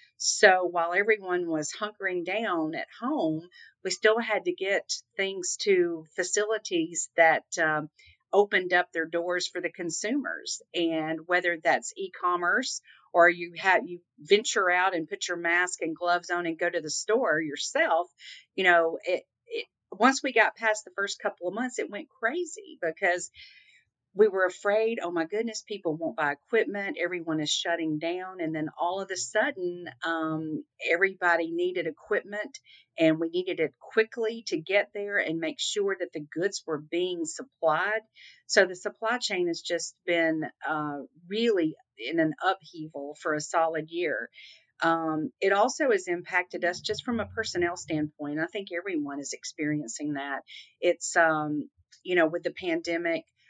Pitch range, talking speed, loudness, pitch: 165-210 Hz, 165 wpm, -28 LUFS, 175 Hz